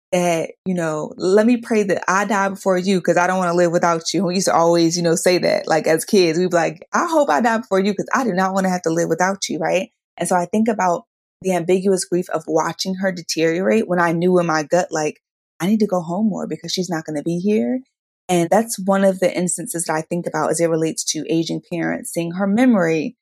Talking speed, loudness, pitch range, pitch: 265 wpm, -19 LUFS, 170-195 Hz, 180 Hz